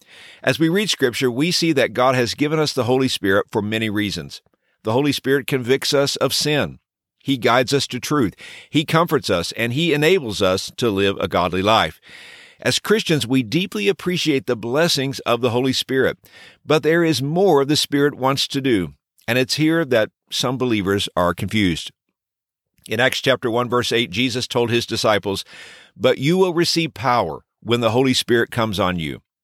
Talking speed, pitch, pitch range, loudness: 185 wpm, 130 Hz, 110-150 Hz, -19 LUFS